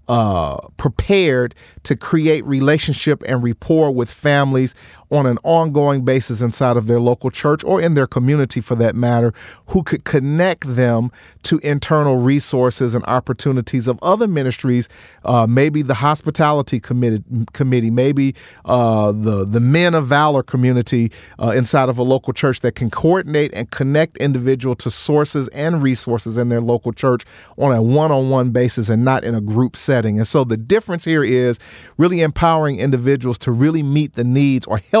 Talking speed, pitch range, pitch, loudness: 165 wpm, 120-150 Hz, 130 Hz, -17 LUFS